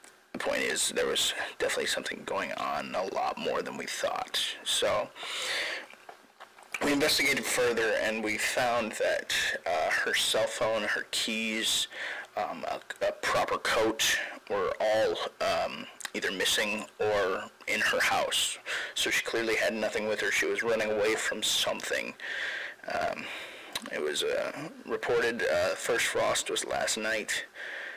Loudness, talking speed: -29 LUFS, 145 wpm